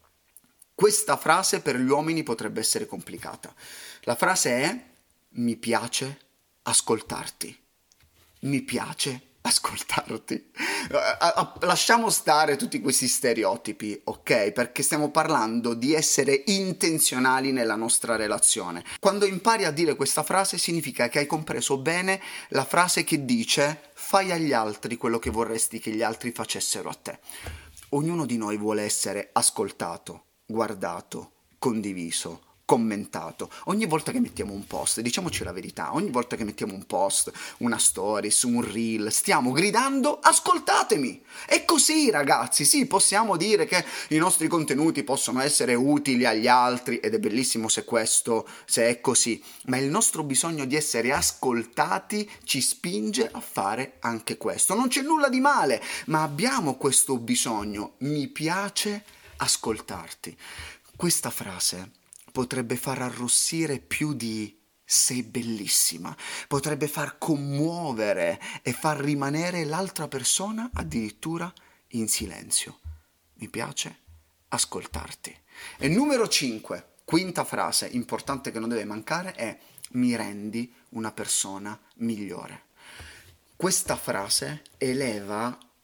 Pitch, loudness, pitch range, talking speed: 135 Hz, -25 LUFS, 115-165 Hz, 130 wpm